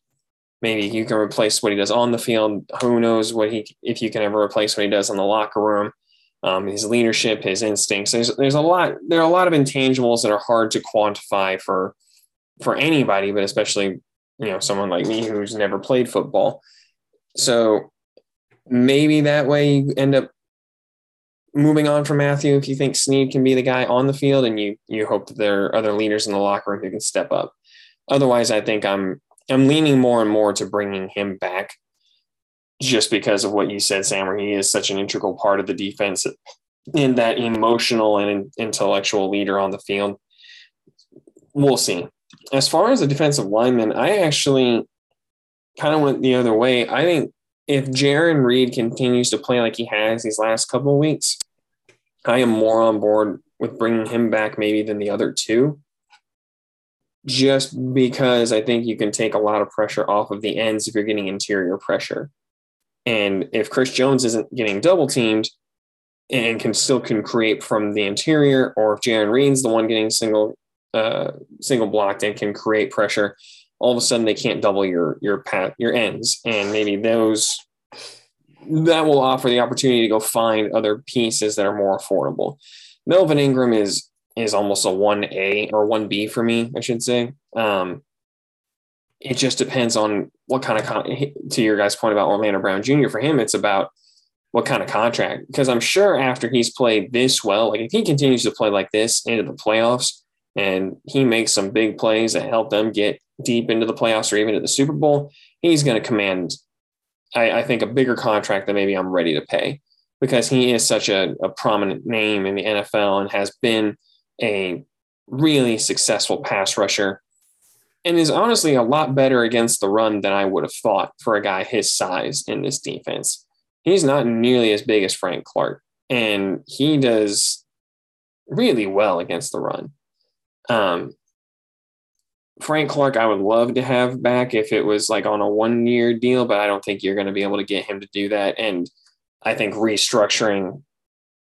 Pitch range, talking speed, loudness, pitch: 105-130 Hz, 190 wpm, -19 LUFS, 115 Hz